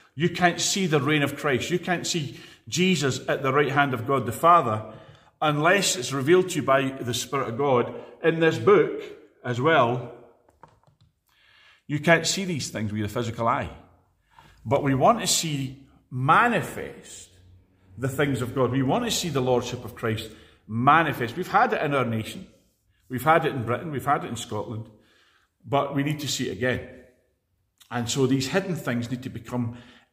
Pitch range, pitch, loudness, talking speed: 120-160 Hz, 135 Hz, -24 LUFS, 185 wpm